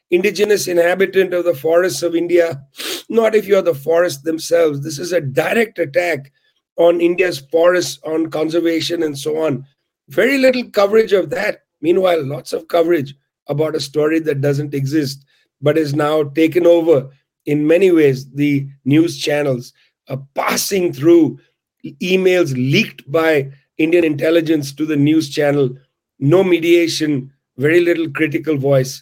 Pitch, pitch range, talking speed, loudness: 160 Hz, 145-175 Hz, 150 wpm, -16 LUFS